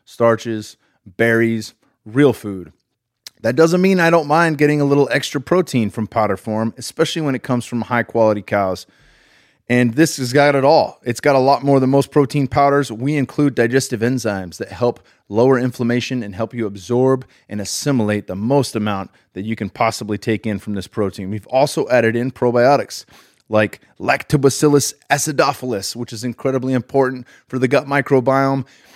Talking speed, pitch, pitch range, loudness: 170 wpm, 125 Hz, 110-140 Hz, -17 LUFS